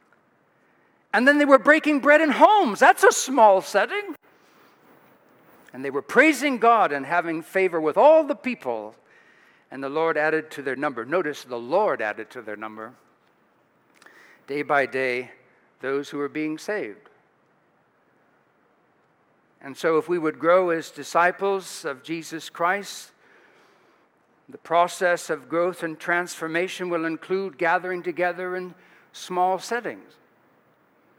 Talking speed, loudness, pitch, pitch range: 135 wpm, -22 LUFS, 175 Hz, 155-210 Hz